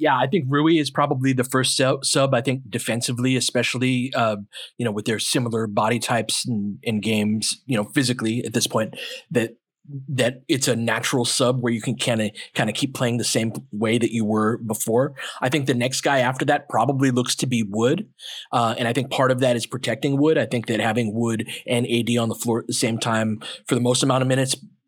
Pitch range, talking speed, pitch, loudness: 115-130 Hz, 225 wpm, 120 Hz, -22 LUFS